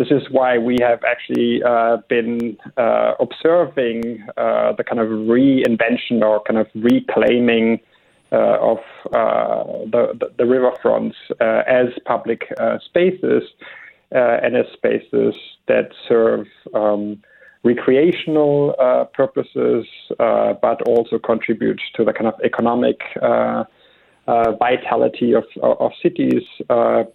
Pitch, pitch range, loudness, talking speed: 115 Hz, 110-125 Hz, -17 LUFS, 130 wpm